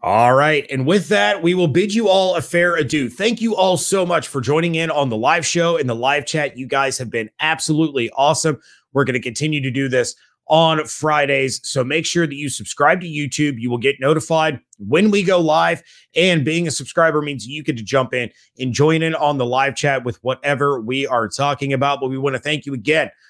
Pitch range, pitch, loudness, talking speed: 130-160 Hz, 145 Hz, -18 LUFS, 230 wpm